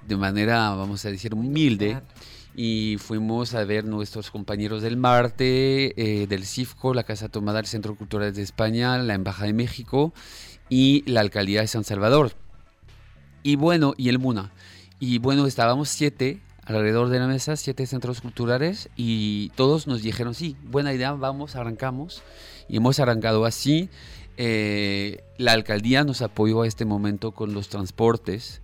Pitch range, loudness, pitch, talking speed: 105-130 Hz, -24 LUFS, 115 Hz, 155 wpm